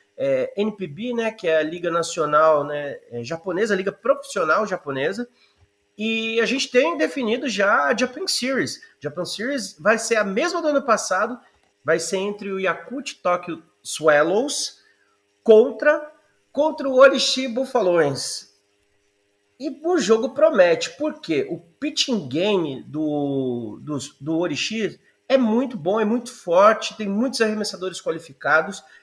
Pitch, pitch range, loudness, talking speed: 210 Hz, 160-265 Hz, -21 LUFS, 135 wpm